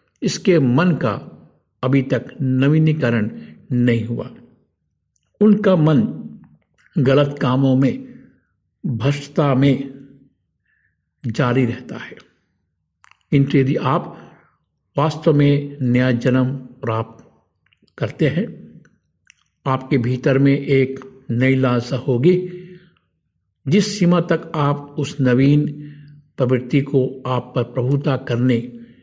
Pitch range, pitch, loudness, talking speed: 125-150 Hz, 135 Hz, -18 LUFS, 95 wpm